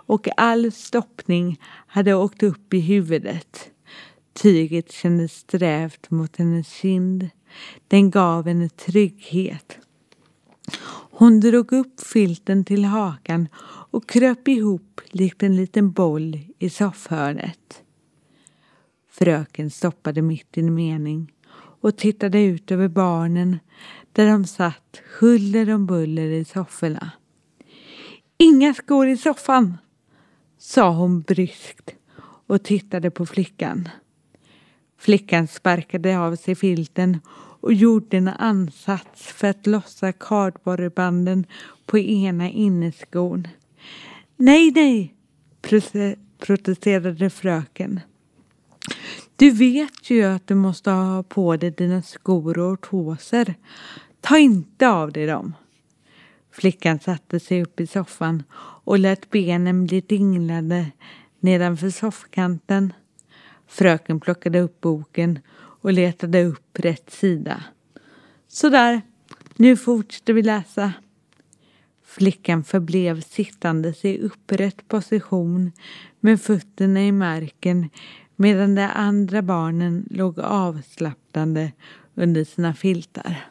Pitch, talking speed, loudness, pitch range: 185 Hz, 105 wpm, -20 LUFS, 170-205 Hz